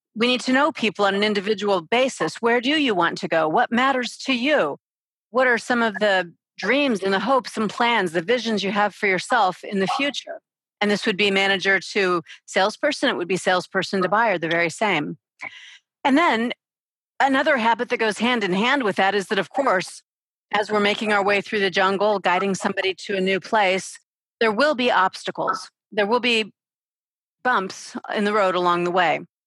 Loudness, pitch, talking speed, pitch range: -21 LUFS, 210 Hz, 200 wpm, 190-245 Hz